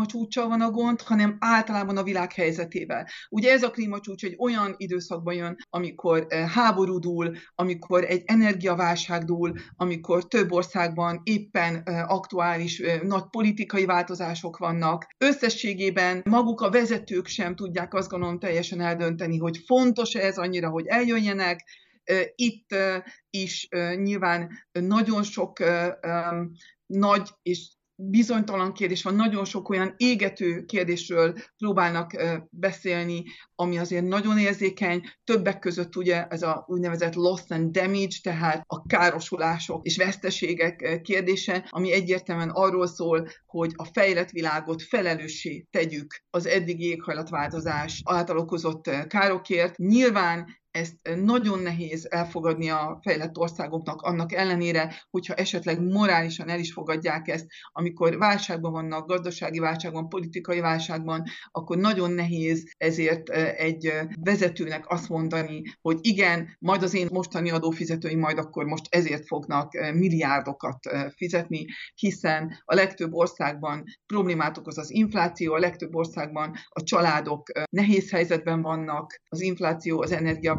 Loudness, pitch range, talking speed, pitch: -26 LUFS, 165-195 Hz, 125 wpm, 175 Hz